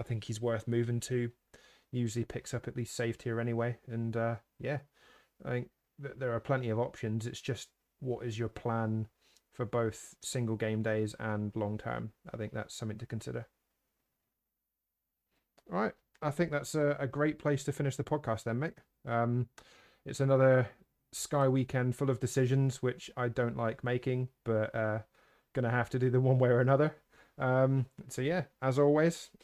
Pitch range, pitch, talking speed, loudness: 115-135 Hz, 120 Hz, 180 wpm, -33 LUFS